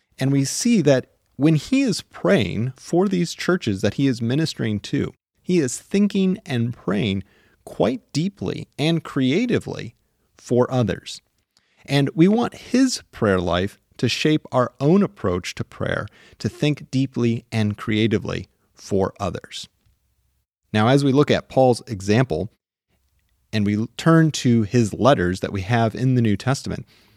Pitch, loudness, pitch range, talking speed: 125 Hz, -21 LUFS, 105-155 Hz, 150 wpm